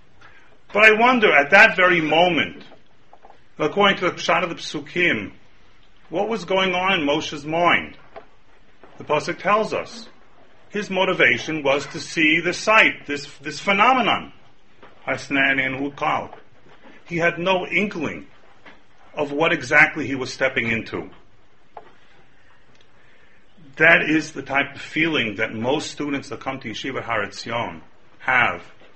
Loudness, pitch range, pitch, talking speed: -19 LUFS, 140-180 Hz, 155 Hz, 130 wpm